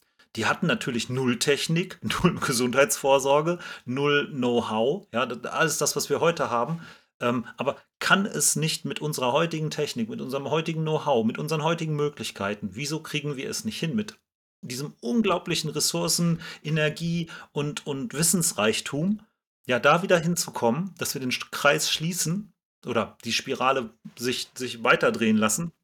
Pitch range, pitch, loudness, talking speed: 130-170 Hz, 150 Hz, -25 LUFS, 145 wpm